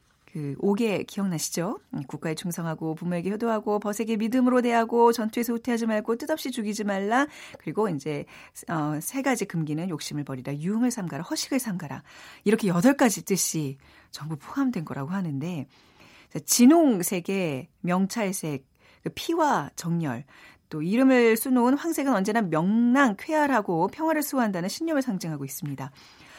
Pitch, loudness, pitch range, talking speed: 200 Hz, -26 LUFS, 160-240 Hz, 340 characters per minute